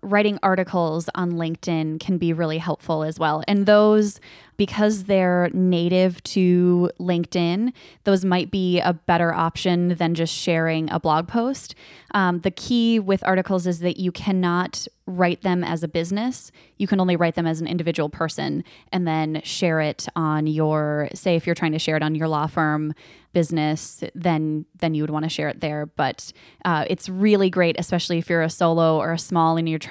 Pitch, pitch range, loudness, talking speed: 170 Hz, 160-185 Hz, -22 LUFS, 190 wpm